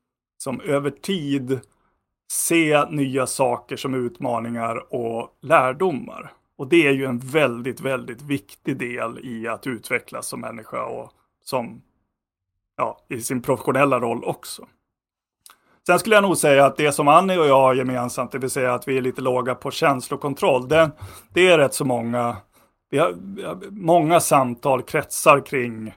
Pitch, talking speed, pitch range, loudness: 135 Hz, 155 wpm, 120-150 Hz, -21 LUFS